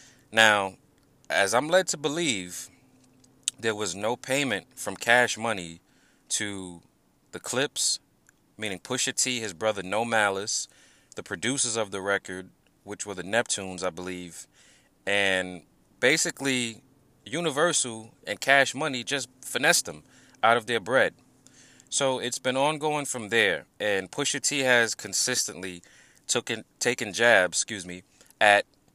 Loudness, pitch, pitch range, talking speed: -25 LUFS, 115 Hz, 100-130 Hz, 135 wpm